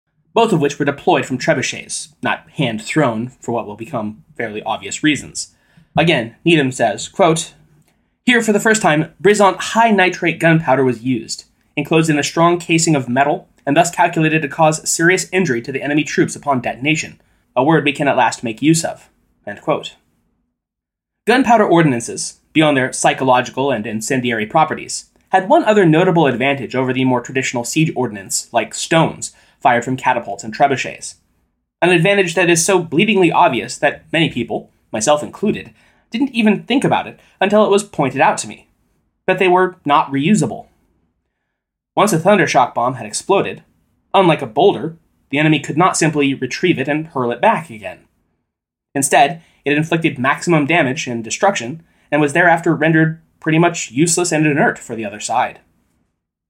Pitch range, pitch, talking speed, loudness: 130-175 Hz, 155 Hz, 170 wpm, -16 LUFS